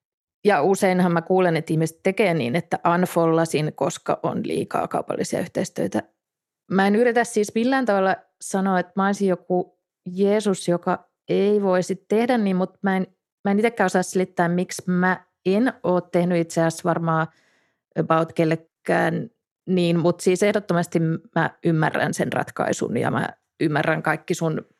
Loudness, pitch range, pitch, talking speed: -22 LUFS, 170-195 Hz, 180 Hz, 150 wpm